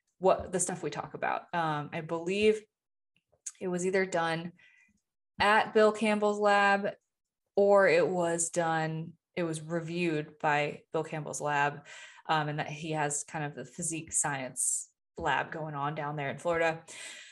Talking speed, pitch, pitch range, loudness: 155 wpm, 165 Hz, 155-190 Hz, -30 LUFS